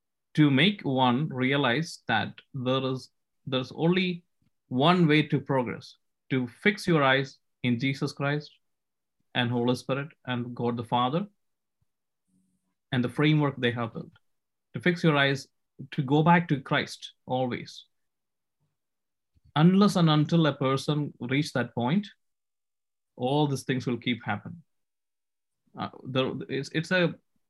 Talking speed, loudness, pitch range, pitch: 135 wpm, -27 LUFS, 125-155 Hz, 135 Hz